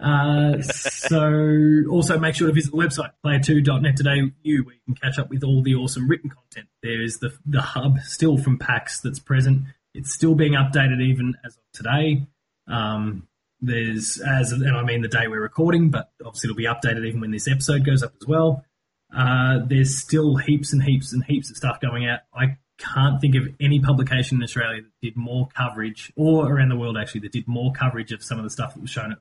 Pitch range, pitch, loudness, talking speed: 120-145 Hz, 135 Hz, -21 LUFS, 220 wpm